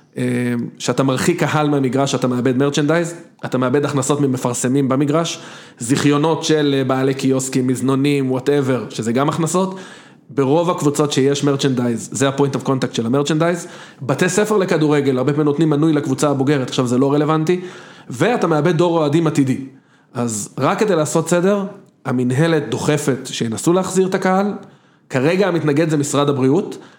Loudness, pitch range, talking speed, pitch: -17 LUFS, 130-165 Hz, 145 wpm, 145 Hz